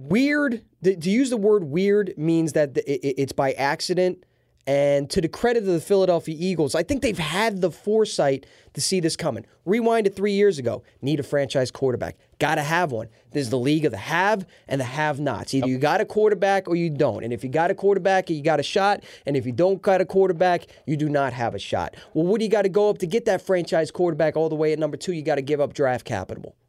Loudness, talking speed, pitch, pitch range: -23 LUFS, 245 wpm, 160 Hz, 140-195 Hz